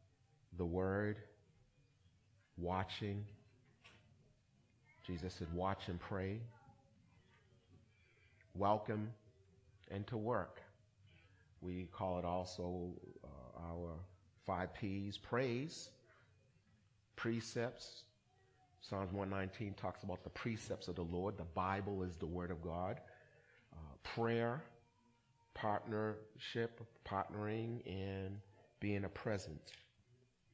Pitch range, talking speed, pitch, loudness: 95-115 Hz, 90 wpm, 100 Hz, -44 LUFS